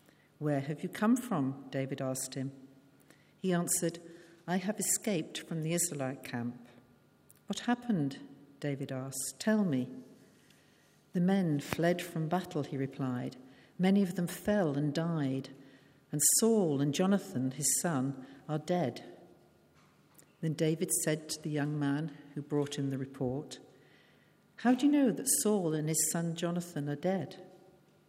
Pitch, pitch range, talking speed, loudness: 155 Hz, 135-180 Hz, 145 wpm, -33 LUFS